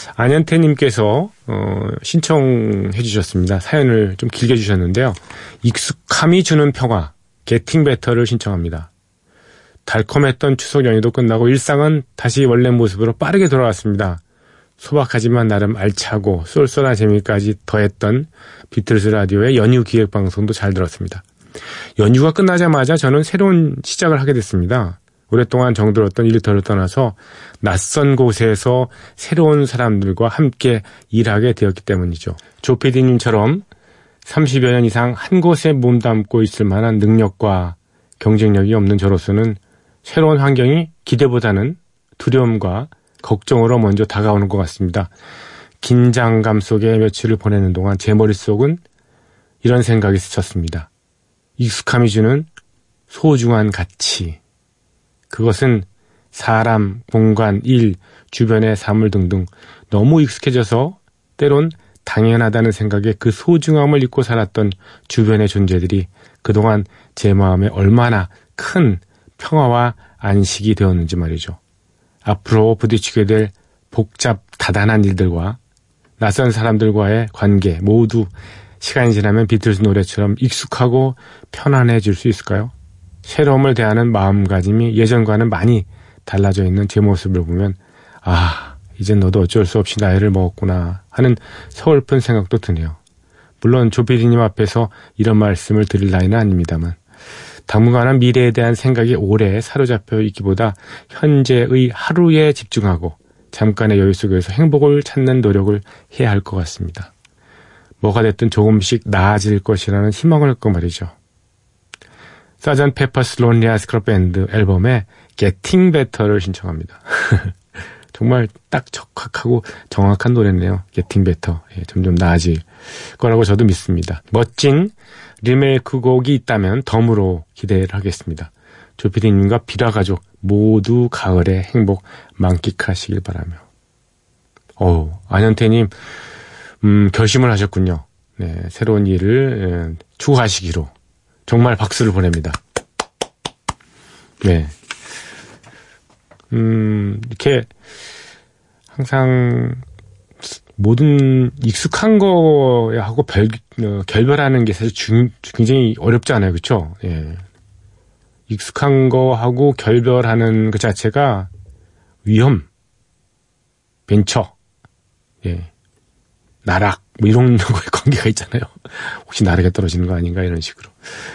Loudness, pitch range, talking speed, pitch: -15 LUFS, 95-120 Hz, 275 characters per minute, 110 Hz